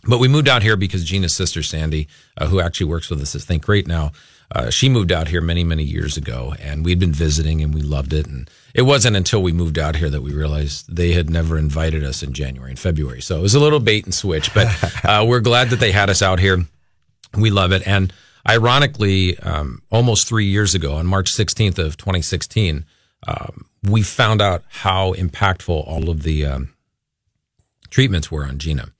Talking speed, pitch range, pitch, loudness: 215 wpm, 80-105 Hz, 90 Hz, -18 LUFS